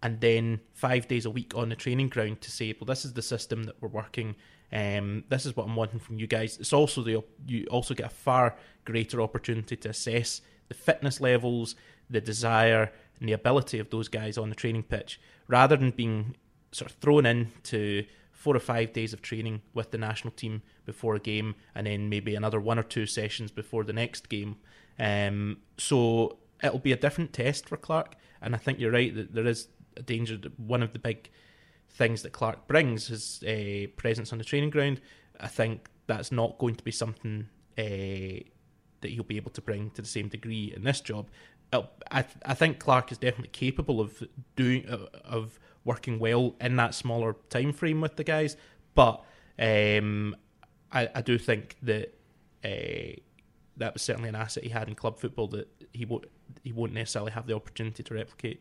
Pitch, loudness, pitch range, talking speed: 115 Hz, -30 LUFS, 110-125 Hz, 200 wpm